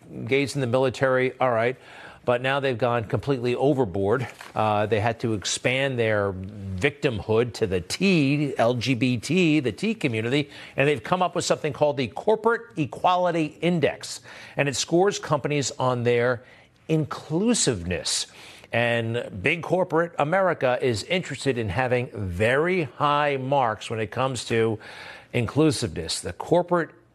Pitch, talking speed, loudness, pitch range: 130 Hz, 135 wpm, -24 LUFS, 115-155 Hz